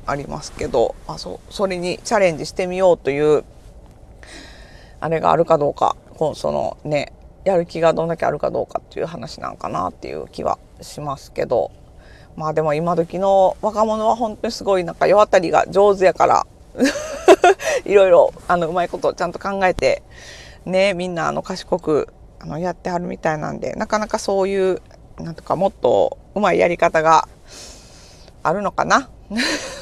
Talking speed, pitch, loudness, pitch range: 335 characters per minute, 185 Hz, -19 LUFS, 170-215 Hz